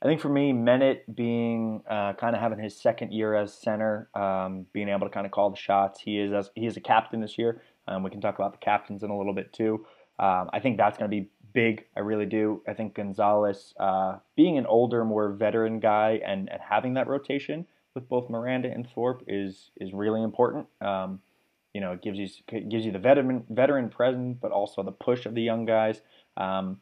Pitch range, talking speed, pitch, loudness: 100-115 Hz, 230 wpm, 110 Hz, -27 LUFS